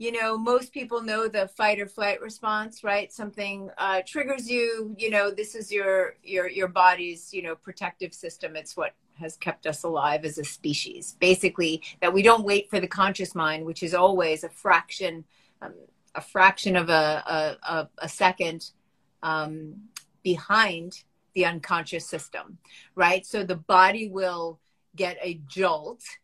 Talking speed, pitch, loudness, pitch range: 165 wpm, 185 Hz, -25 LUFS, 165-205 Hz